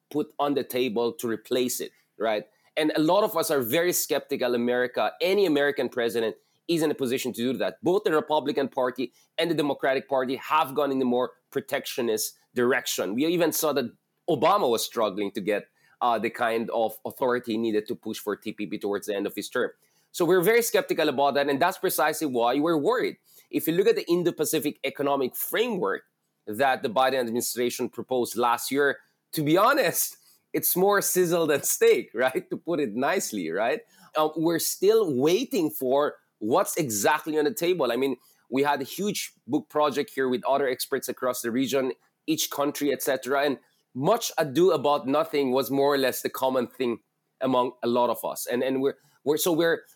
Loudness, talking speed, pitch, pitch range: -26 LUFS, 190 wpm, 140 Hz, 125-165 Hz